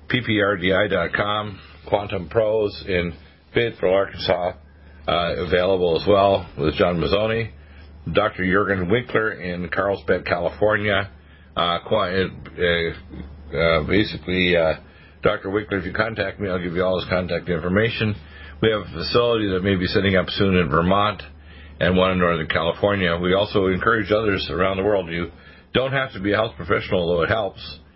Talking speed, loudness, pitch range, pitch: 150 wpm, -21 LUFS, 85-105 Hz, 95 Hz